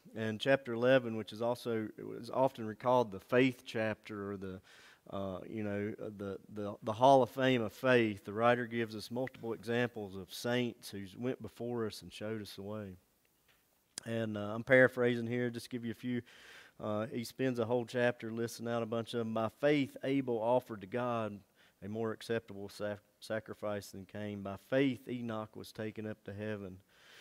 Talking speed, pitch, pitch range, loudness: 185 wpm, 115 Hz, 105-120 Hz, -35 LUFS